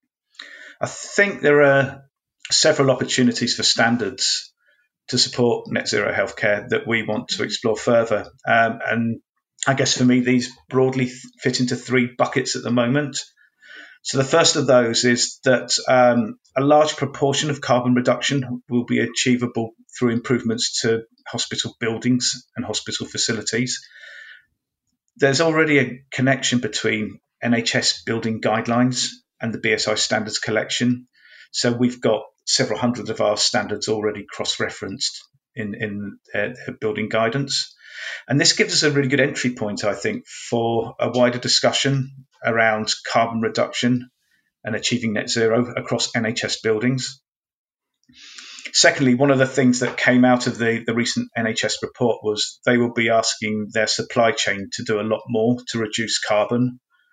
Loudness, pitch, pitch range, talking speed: -20 LUFS, 125 Hz, 115-135 Hz, 150 wpm